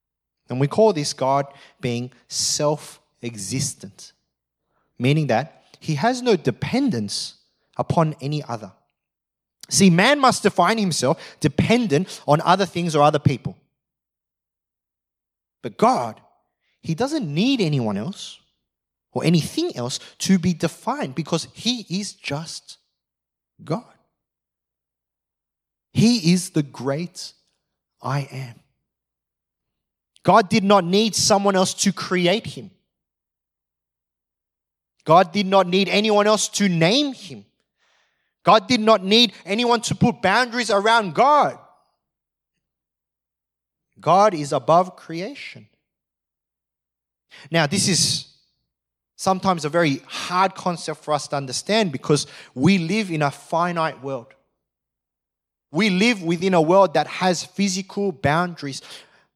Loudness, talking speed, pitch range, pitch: -20 LUFS, 115 wpm, 130-195 Hz, 165 Hz